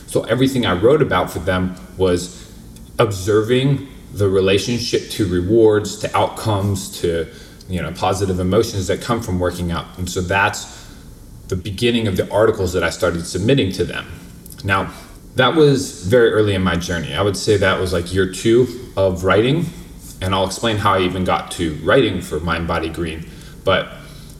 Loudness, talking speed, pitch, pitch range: -18 LUFS, 175 wpm, 95 Hz, 90-110 Hz